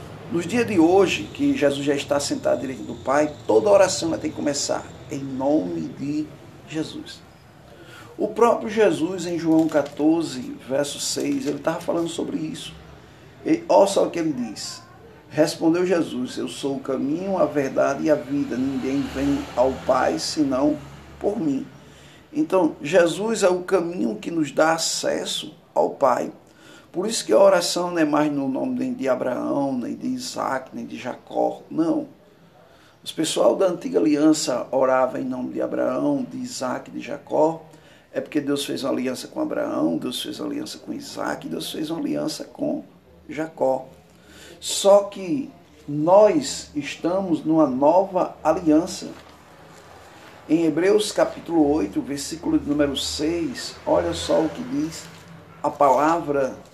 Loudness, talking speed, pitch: -22 LUFS, 155 wpm, 195 Hz